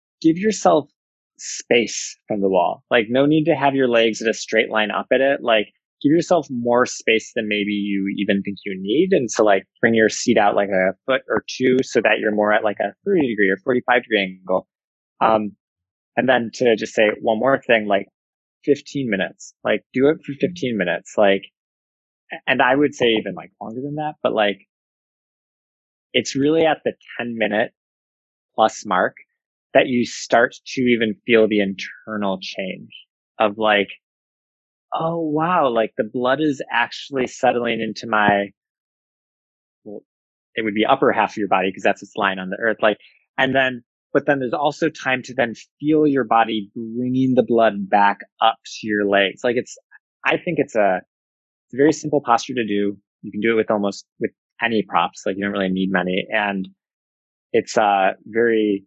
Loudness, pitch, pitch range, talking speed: -19 LUFS, 110 Hz, 100-130 Hz, 190 wpm